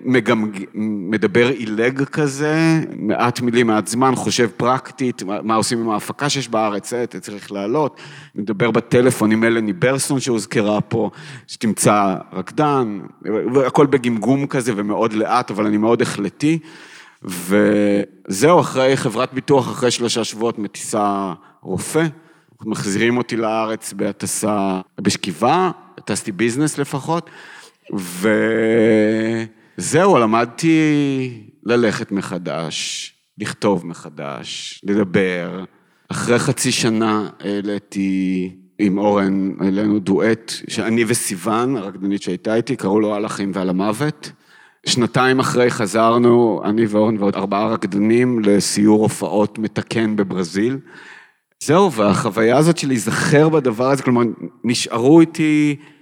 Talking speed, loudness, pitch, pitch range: 110 wpm, -18 LUFS, 115 Hz, 105-130 Hz